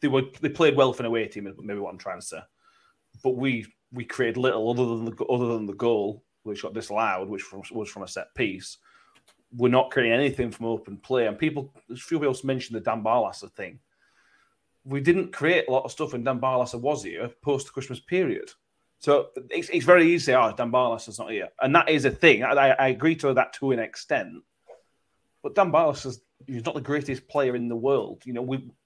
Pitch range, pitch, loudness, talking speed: 120-145 Hz, 130 Hz, -25 LUFS, 225 wpm